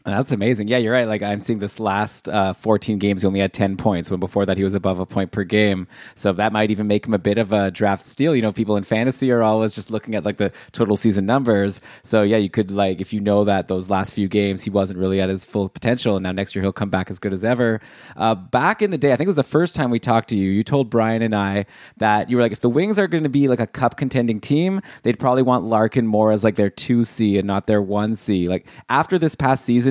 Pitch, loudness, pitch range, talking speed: 105 Hz, -20 LUFS, 100-120 Hz, 285 wpm